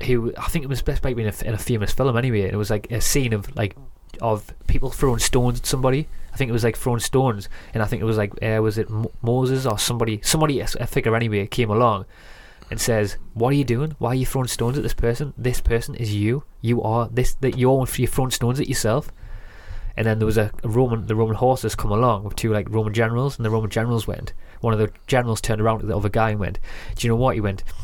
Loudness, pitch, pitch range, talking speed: -22 LUFS, 115 Hz, 105-125 Hz, 250 wpm